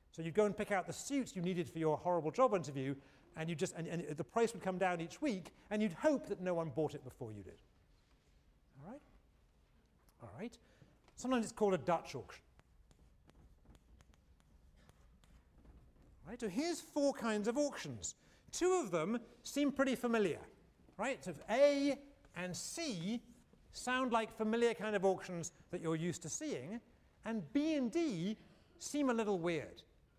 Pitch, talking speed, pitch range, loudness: 185 Hz, 170 wpm, 150-240 Hz, -38 LUFS